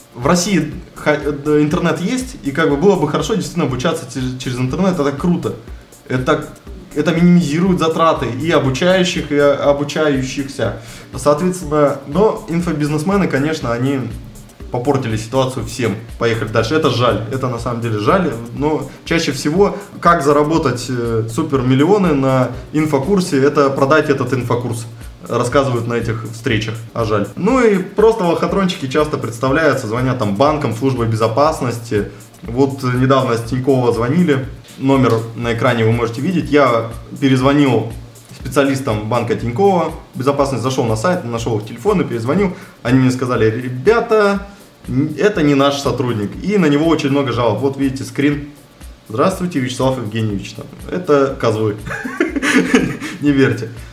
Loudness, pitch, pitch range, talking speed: -16 LUFS, 140 Hz, 120-155 Hz, 130 wpm